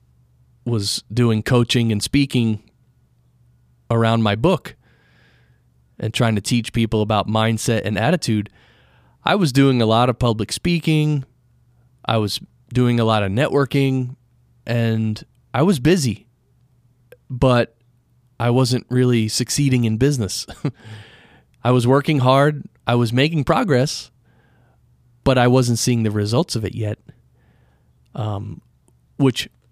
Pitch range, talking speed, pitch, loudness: 110-130 Hz, 125 wpm, 120 Hz, -19 LUFS